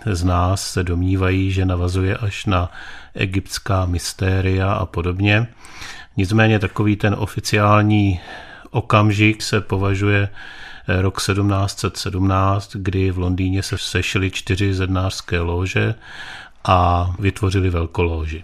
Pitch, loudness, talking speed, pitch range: 95 Hz, -19 LUFS, 105 wpm, 95-105 Hz